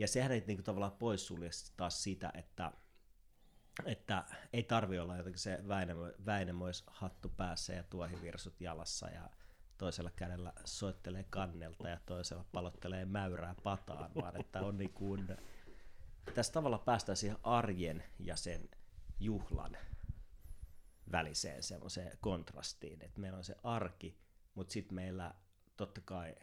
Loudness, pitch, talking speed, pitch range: -43 LUFS, 90 Hz, 125 wpm, 85-100 Hz